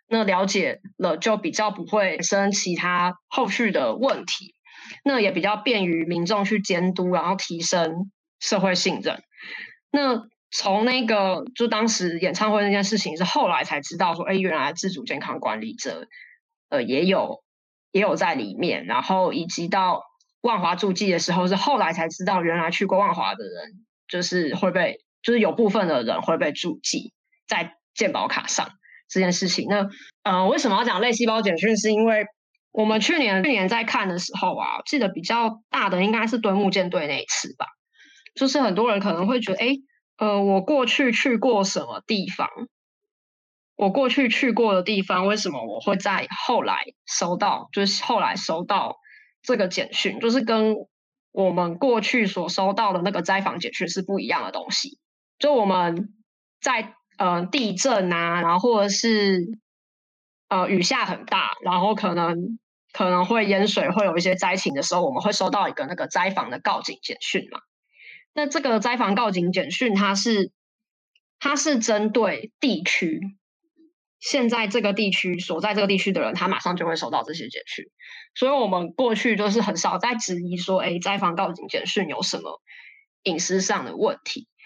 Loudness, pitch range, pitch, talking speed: -23 LUFS, 190-240 Hz, 210 Hz, 260 characters per minute